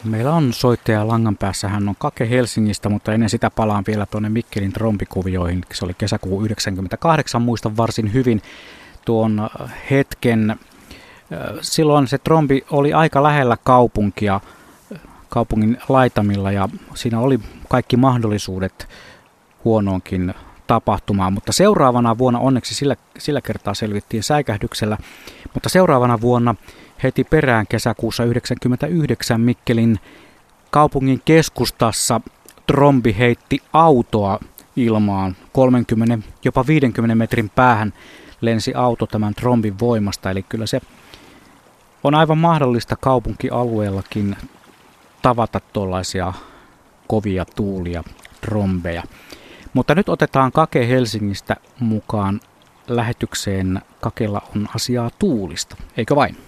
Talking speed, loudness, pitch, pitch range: 105 wpm, -18 LUFS, 115 Hz, 105-125 Hz